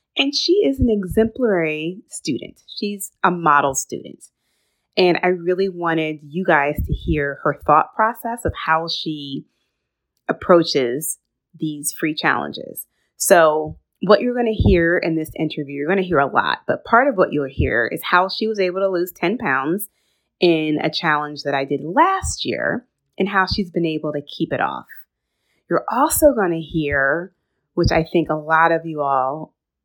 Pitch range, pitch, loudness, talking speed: 150-190 Hz, 165 Hz, -19 LUFS, 170 wpm